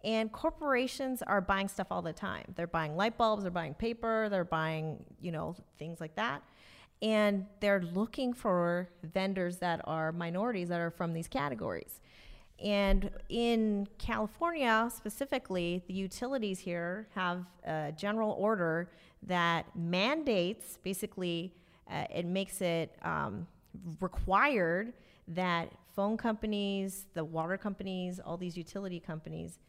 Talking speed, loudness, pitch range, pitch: 130 wpm, -34 LUFS, 170-210 Hz, 190 Hz